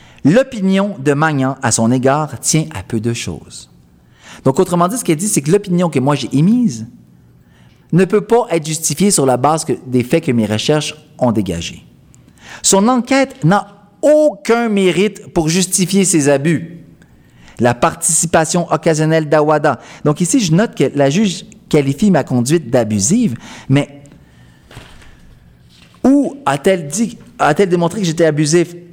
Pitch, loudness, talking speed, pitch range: 160 Hz, -14 LUFS, 150 wpm, 130-190 Hz